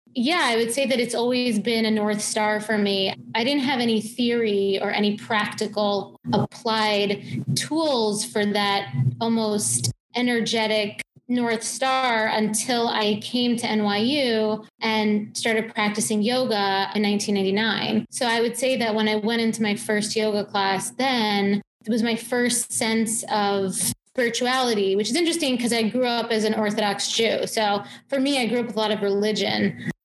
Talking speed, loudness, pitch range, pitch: 165 wpm, -23 LUFS, 210-235 Hz, 220 Hz